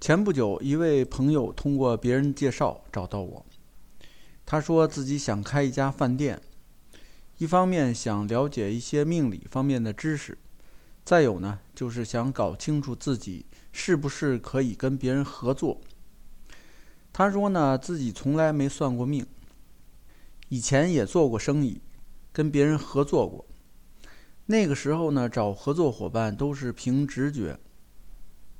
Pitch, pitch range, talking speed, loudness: 135 Hz, 120-145 Hz, 210 characters per minute, -26 LUFS